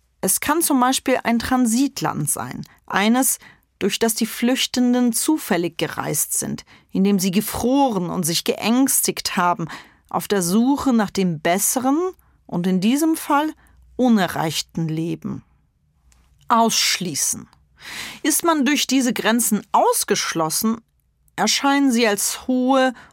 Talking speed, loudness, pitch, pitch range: 115 wpm, -19 LUFS, 230 Hz, 185-260 Hz